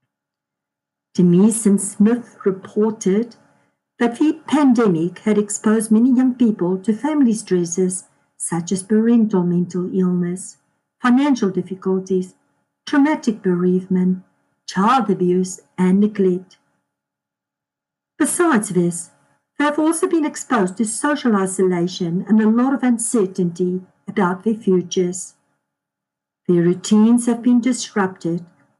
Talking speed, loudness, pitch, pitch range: 105 wpm, -18 LUFS, 195 Hz, 180-230 Hz